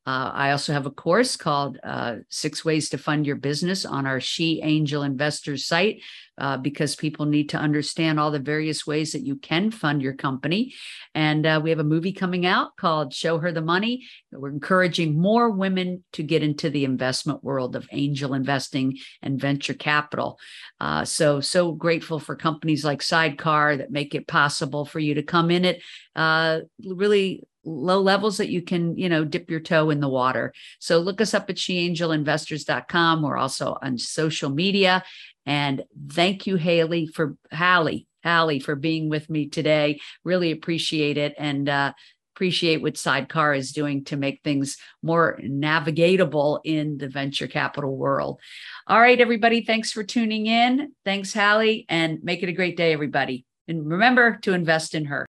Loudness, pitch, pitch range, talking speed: -23 LUFS, 160 Hz, 145-180 Hz, 175 wpm